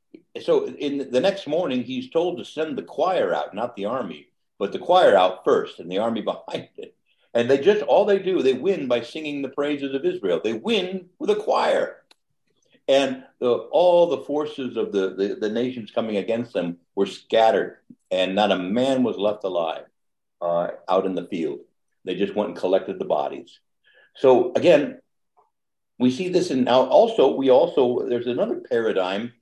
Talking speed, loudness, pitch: 185 wpm, -22 LUFS, 150 Hz